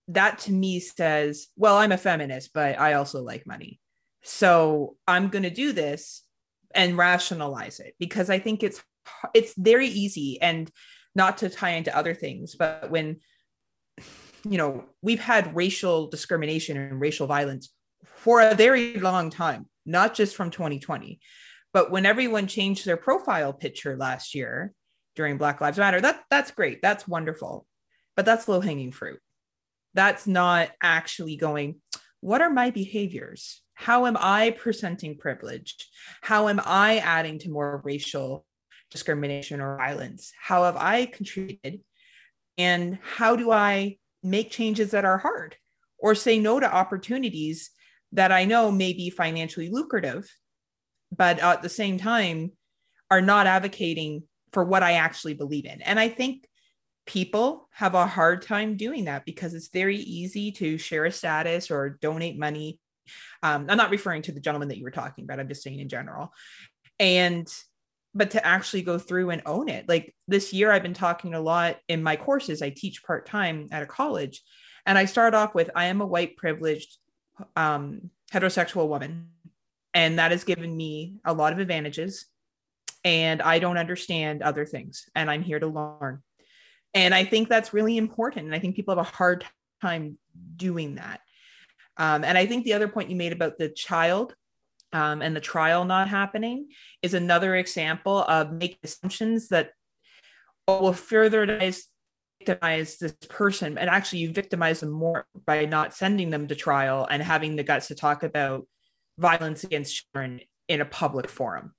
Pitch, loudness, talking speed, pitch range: 175 Hz, -24 LUFS, 165 wpm, 155-200 Hz